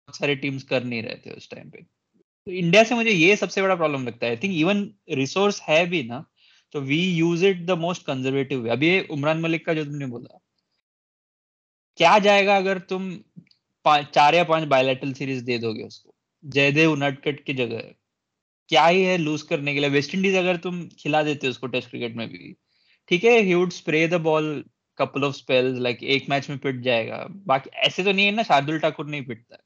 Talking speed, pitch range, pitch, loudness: 105 wpm, 135-180 Hz, 155 Hz, -21 LUFS